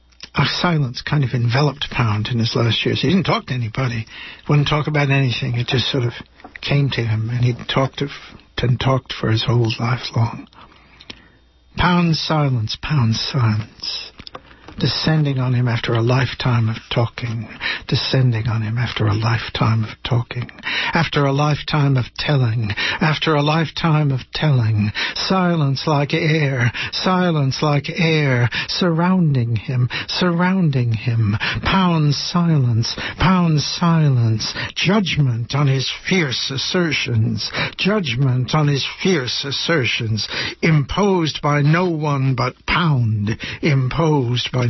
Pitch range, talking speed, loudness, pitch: 120-155 Hz, 130 wpm, -18 LUFS, 135 Hz